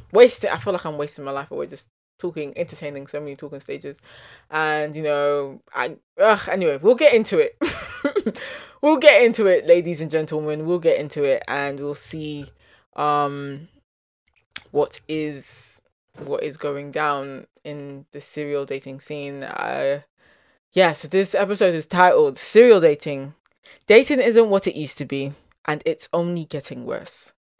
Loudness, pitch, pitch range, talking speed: -20 LUFS, 150 Hz, 140-180 Hz, 160 wpm